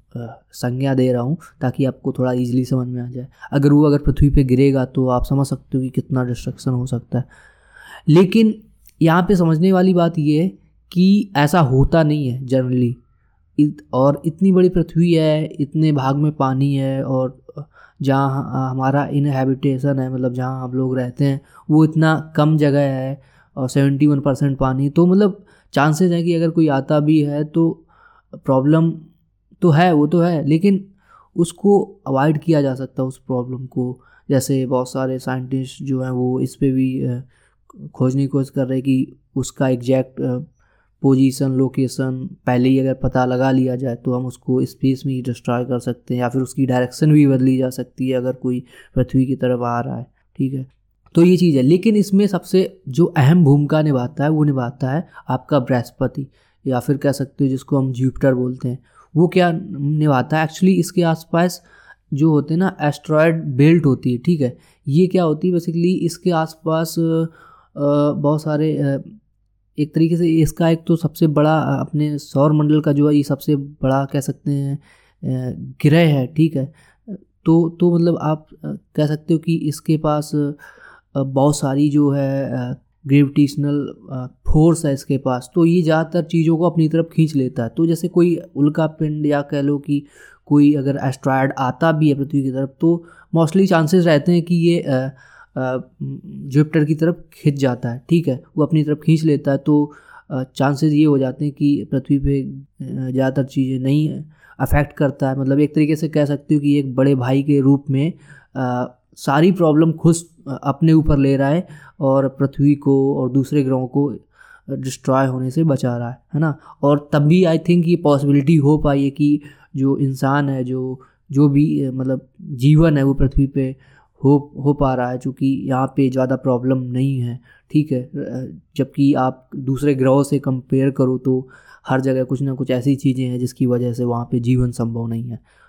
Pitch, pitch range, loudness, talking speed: 140 Hz, 130-155 Hz, -18 LUFS, 185 wpm